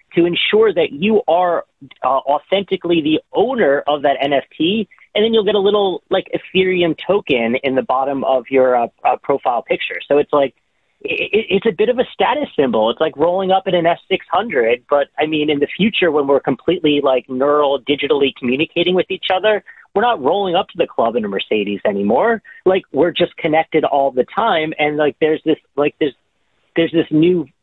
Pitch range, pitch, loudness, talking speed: 140-190 Hz, 160 Hz, -16 LUFS, 200 wpm